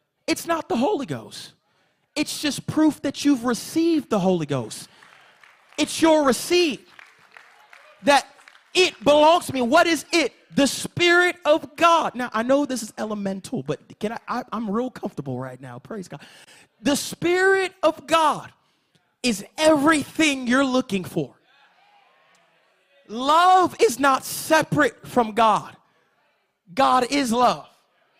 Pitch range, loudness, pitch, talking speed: 220-320 Hz, -21 LUFS, 275 Hz, 135 wpm